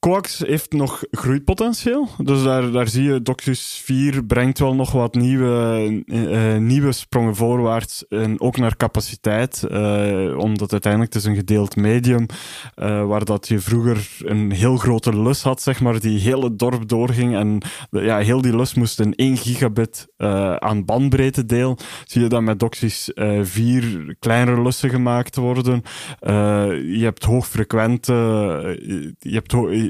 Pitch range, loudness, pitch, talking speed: 110-130 Hz, -19 LUFS, 120 Hz, 165 wpm